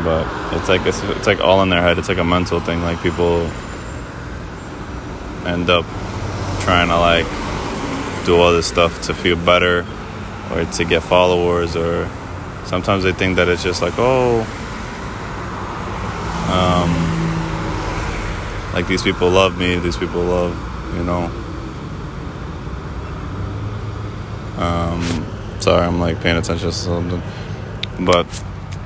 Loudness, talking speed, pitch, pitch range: -18 LUFS, 130 wpm, 90 Hz, 85-100 Hz